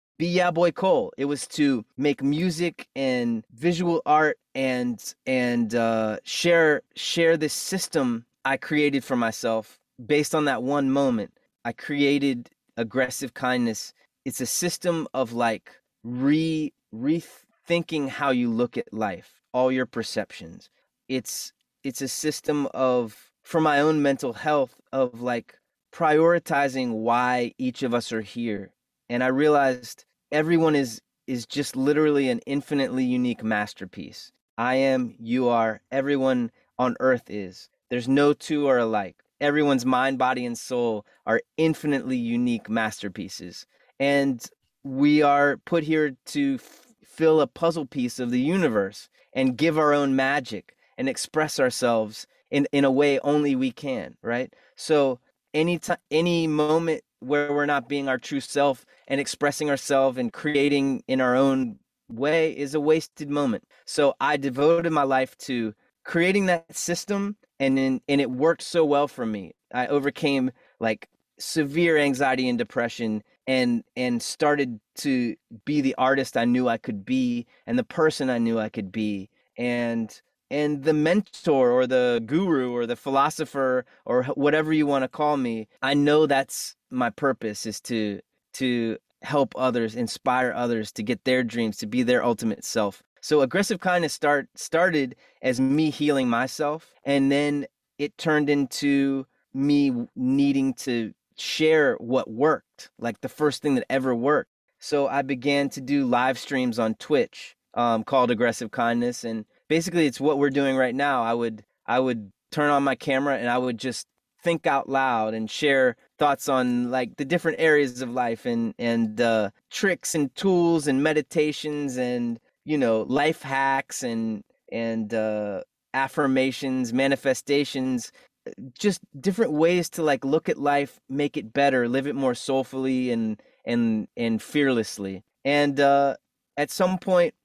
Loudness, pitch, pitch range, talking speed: -24 LUFS, 140 Hz, 125-155 Hz, 155 wpm